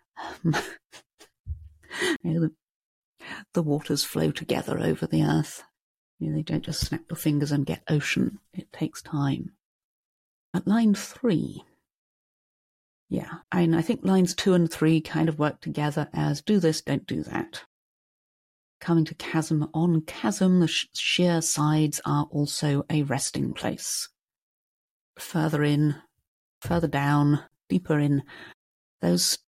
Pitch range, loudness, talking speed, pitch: 145-165 Hz, -26 LUFS, 135 wpm, 155 Hz